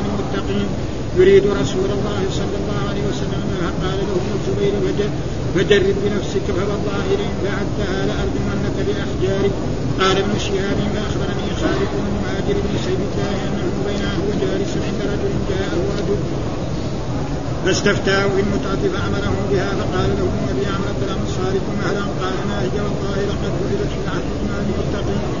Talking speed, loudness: 135 wpm, -20 LUFS